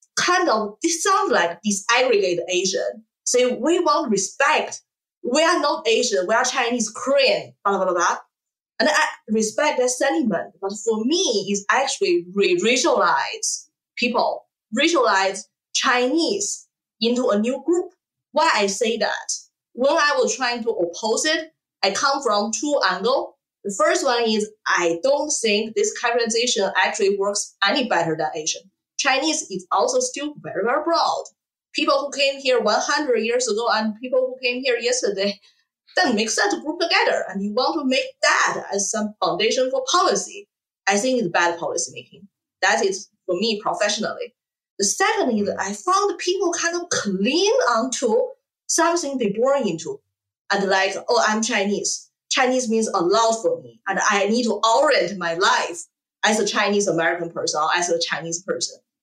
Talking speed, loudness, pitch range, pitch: 165 wpm, -20 LUFS, 200-315 Hz, 240 Hz